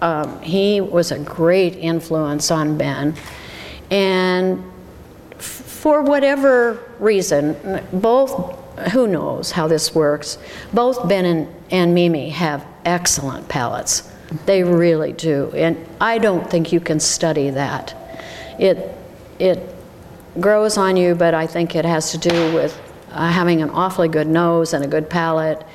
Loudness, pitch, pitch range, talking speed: -18 LUFS, 170 Hz, 160-185 Hz, 135 wpm